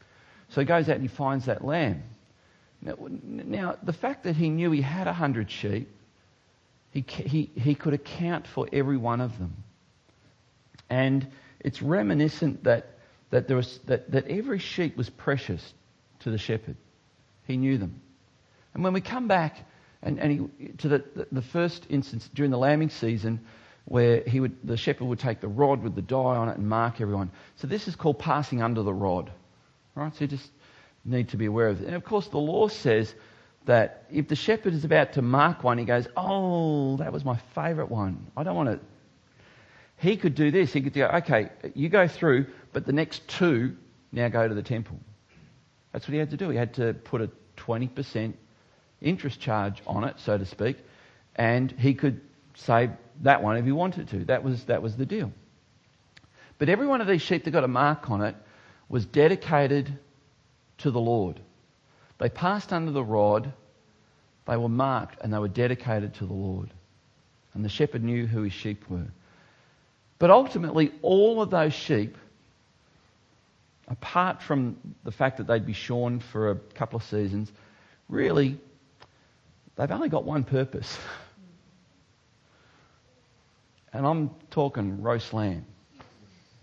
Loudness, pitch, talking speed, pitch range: -27 LUFS, 130 Hz, 175 wpm, 110-150 Hz